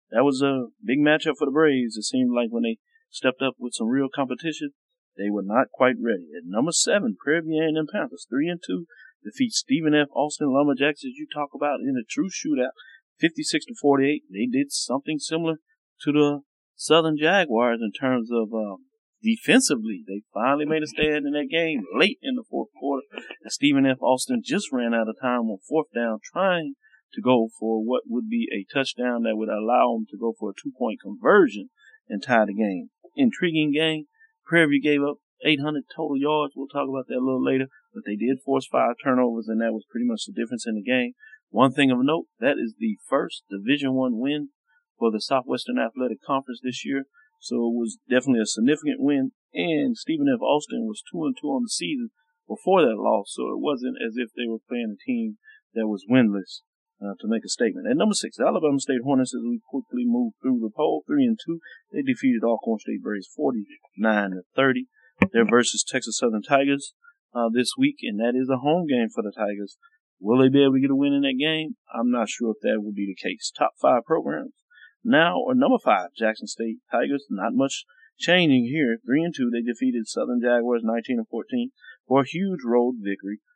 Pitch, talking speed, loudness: 150 Hz, 210 wpm, -24 LUFS